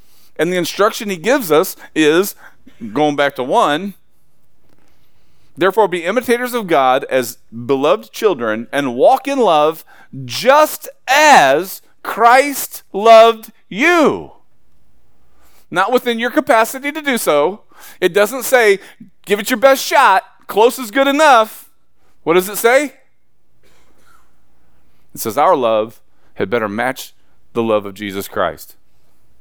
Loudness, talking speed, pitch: -14 LUFS, 130 wpm, 220 Hz